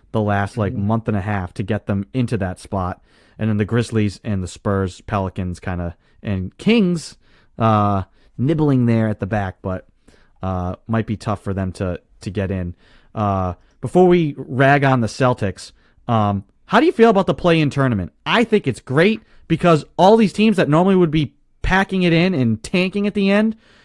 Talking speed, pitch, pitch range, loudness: 200 wpm, 115 Hz, 100-165 Hz, -18 LUFS